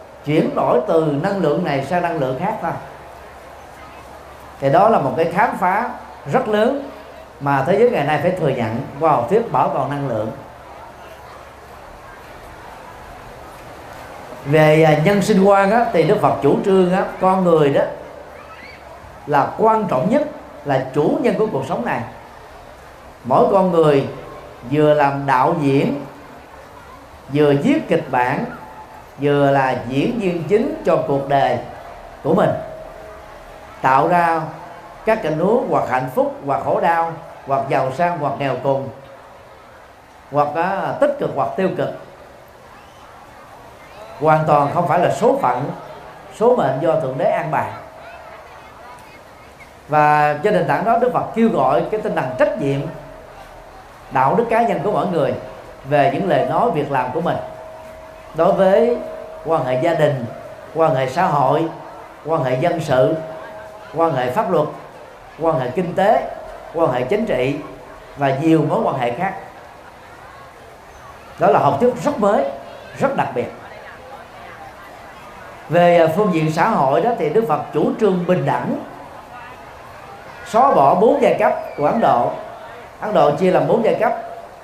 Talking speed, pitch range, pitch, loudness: 150 wpm, 140-200 Hz, 160 Hz, -17 LUFS